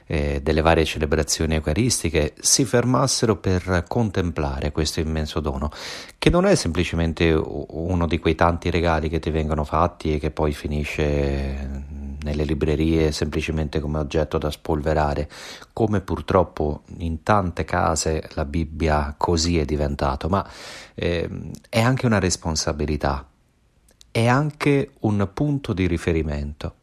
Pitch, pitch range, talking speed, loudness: 80 Hz, 75-90 Hz, 130 wpm, -22 LUFS